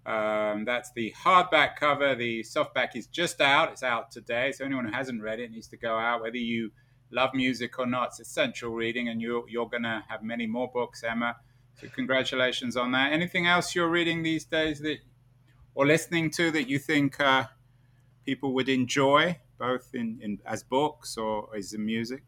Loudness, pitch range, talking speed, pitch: -27 LUFS, 115-140 Hz, 195 wpm, 125 Hz